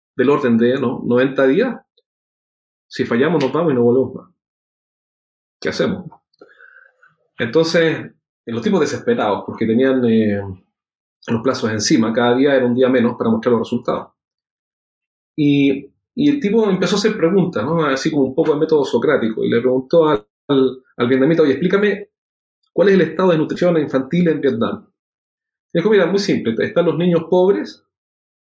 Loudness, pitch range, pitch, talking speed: -17 LUFS, 130-180 Hz, 145 Hz, 170 wpm